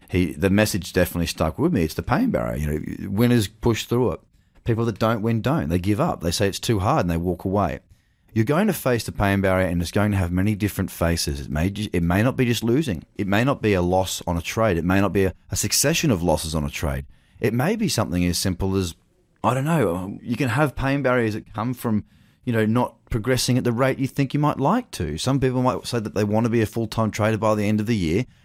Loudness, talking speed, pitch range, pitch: -22 LUFS, 270 wpm, 95-120 Hz, 105 Hz